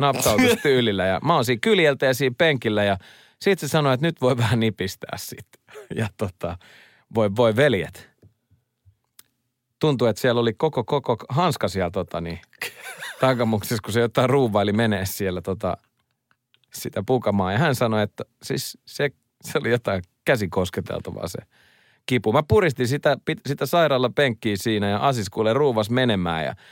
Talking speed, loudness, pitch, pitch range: 155 wpm, -22 LUFS, 120 Hz, 105-135 Hz